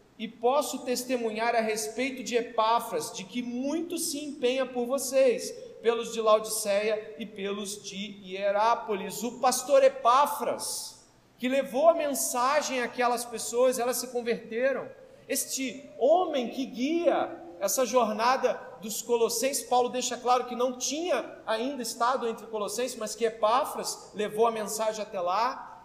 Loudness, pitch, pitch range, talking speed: -28 LUFS, 245 Hz, 225-265 Hz, 135 wpm